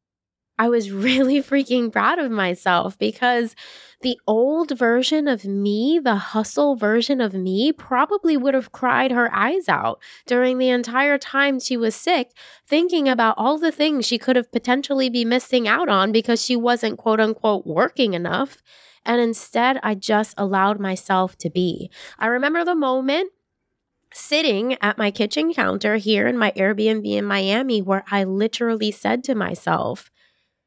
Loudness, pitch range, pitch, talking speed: -20 LUFS, 210-270 Hz, 240 Hz, 160 wpm